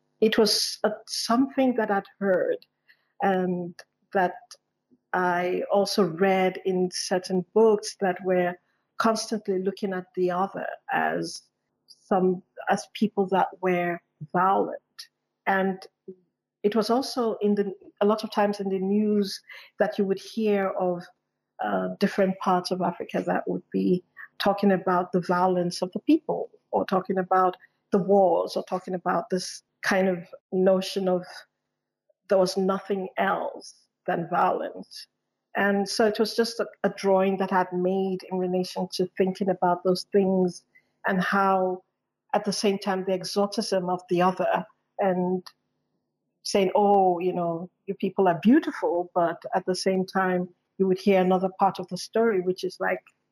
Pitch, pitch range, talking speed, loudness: 190 Hz, 185-205 Hz, 155 wpm, -25 LUFS